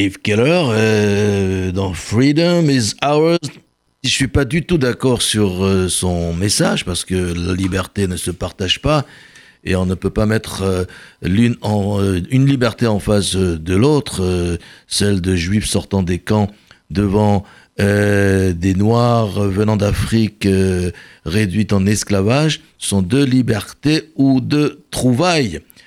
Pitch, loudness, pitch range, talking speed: 100 Hz, -16 LUFS, 95-120 Hz, 150 wpm